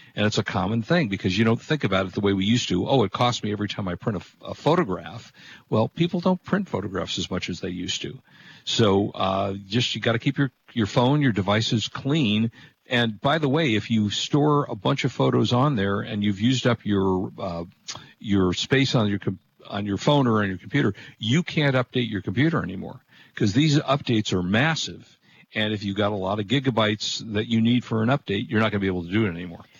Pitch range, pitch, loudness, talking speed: 100-130 Hz, 110 Hz, -23 LUFS, 240 wpm